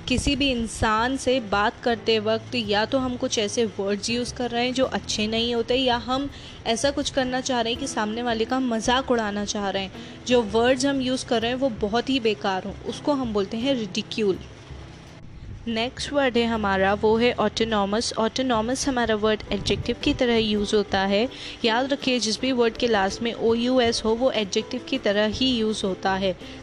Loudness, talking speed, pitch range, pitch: -23 LUFS, 205 wpm, 215-255 Hz, 230 Hz